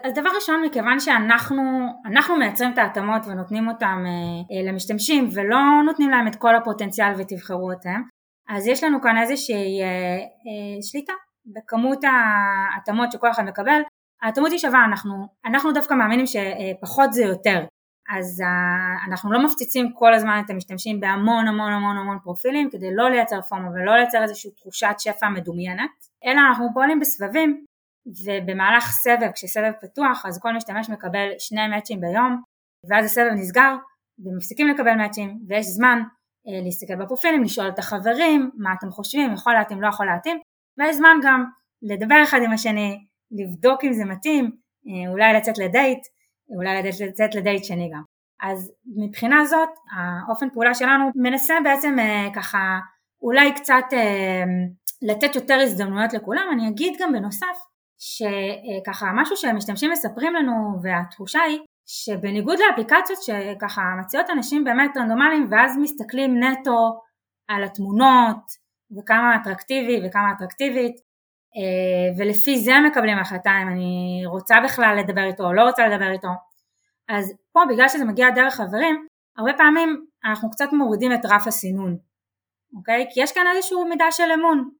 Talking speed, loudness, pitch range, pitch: 150 wpm, -20 LUFS, 200-270 Hz, 225 Hz